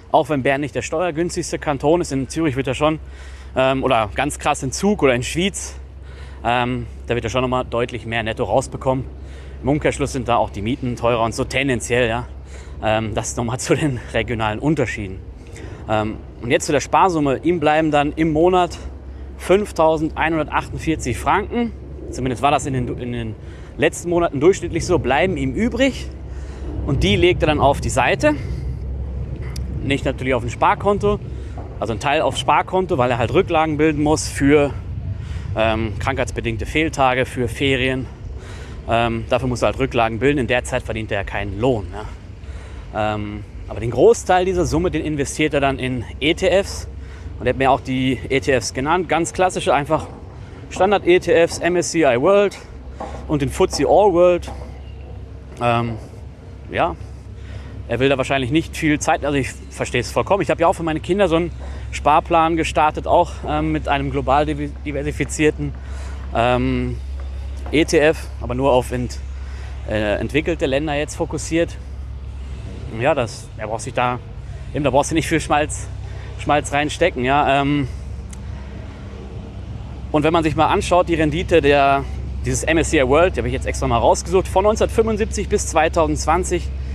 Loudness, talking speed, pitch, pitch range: -19 LUFS, 160 wpm, 125 Hz, 100-155 Hz